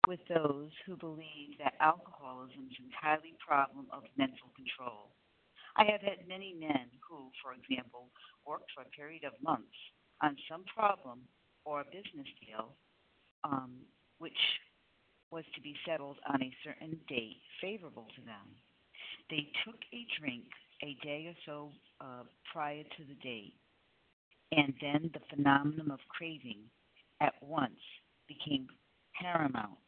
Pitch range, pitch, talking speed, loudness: 135-165 Hz, 150 Hz, 140 wpm, -37 LUFS